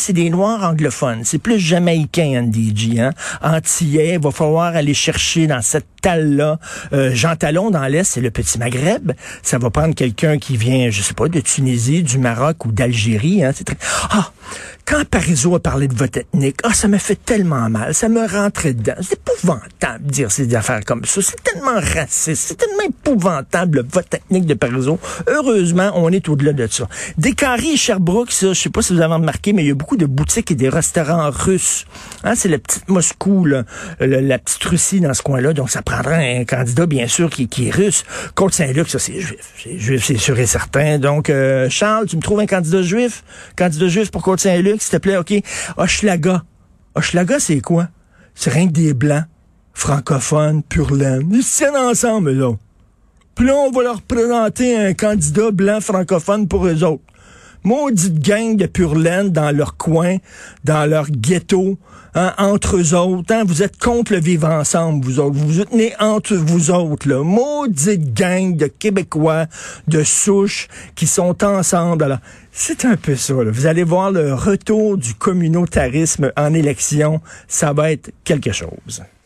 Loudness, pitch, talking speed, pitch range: -16 LUFS, 165 Hz, 190 wpm, 140-195 Hz